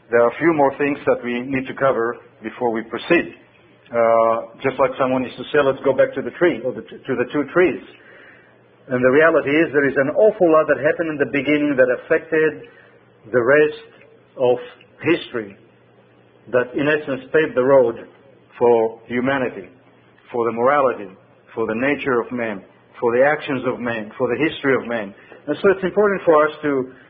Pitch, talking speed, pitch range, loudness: 135 Hz, 195 wpm, 120-150 Hz, -19 LUFS